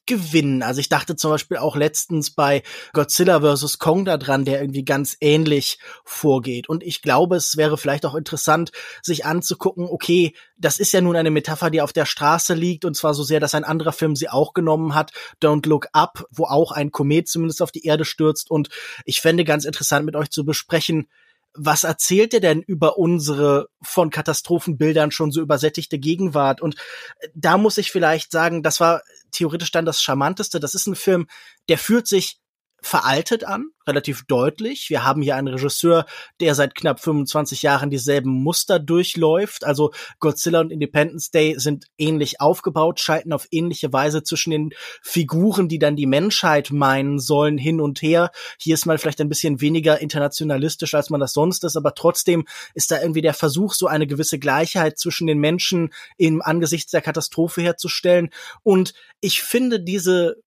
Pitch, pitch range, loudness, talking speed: 155 Hz, 150-170 Hz, -19 LUFS, 180 wpm